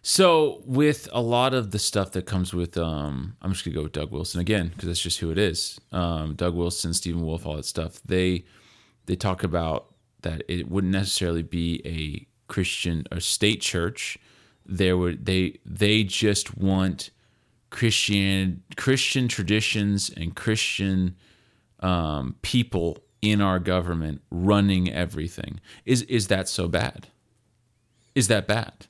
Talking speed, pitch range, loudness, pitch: 150 wpm, 85-105 Hz, -25 LUFS, 95 Hz